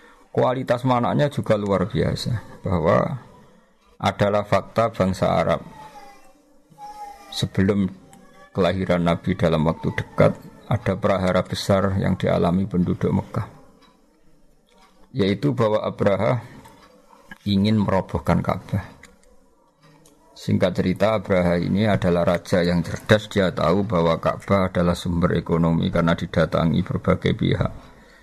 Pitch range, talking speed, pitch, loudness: 90-115 Hz, 100 wpm, 100 Hz, -22 LUFS